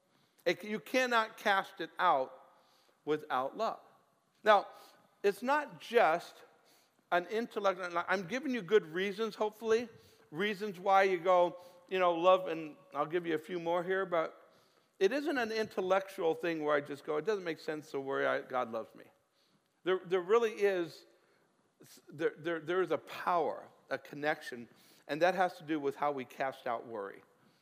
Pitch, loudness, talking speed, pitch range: 185 Hz, -34 LUFS, 170 wpm, 160-215 Hz